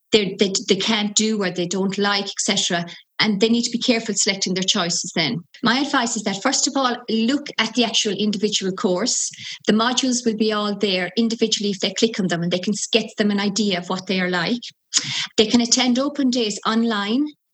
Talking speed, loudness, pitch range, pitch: 215 wpm, -20 LUFS, 200-235 Hz, 215 Hz